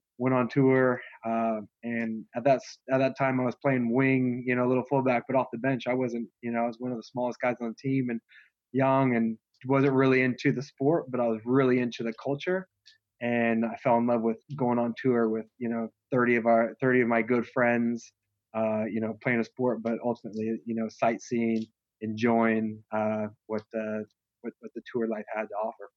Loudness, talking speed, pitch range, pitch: -28 LUFS, 220 wpm, 115-130 Hz, 120 Hz